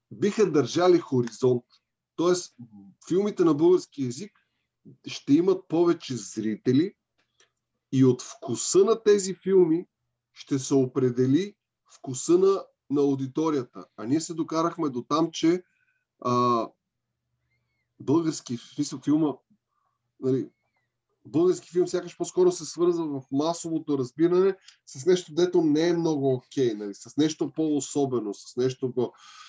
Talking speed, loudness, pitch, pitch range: 120 wpm, -25 LUFS, 155 Hz, 130-180 Hz